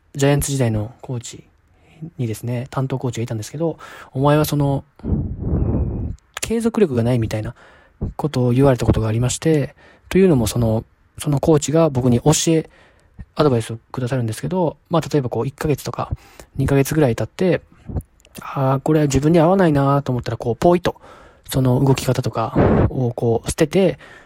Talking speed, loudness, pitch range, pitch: 360 characters per minute, -19 LUFS, 115-150 Hz, 135 Hz